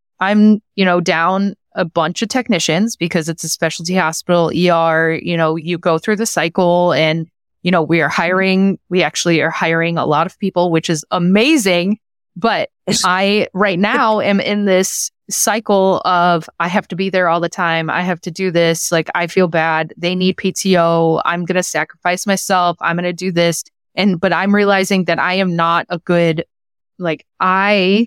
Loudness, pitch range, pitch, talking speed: -15 LUFS, 165-195 Hz, 180 Hz, 190 wpm